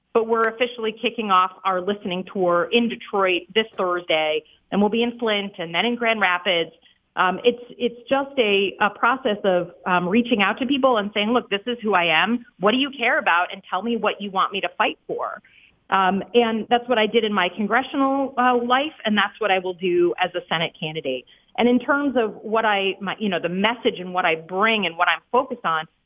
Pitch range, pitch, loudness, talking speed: 180-235 Hz, 210 Hz, -21 LUFS, 230 wpm